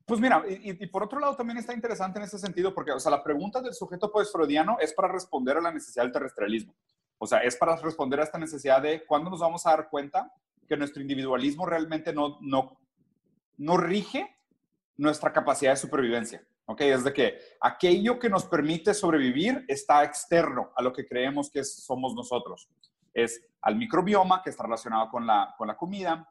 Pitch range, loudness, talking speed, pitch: 140-200 Hz, -27 LUFS, 195 wpm, 165 Hz